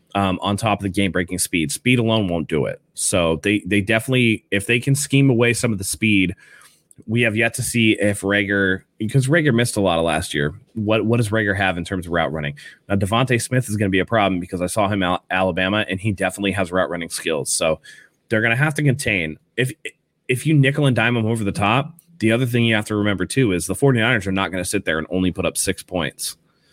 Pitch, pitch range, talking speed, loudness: 105 Hz, 95-120 Hz, 255 wpm, -19 LUFS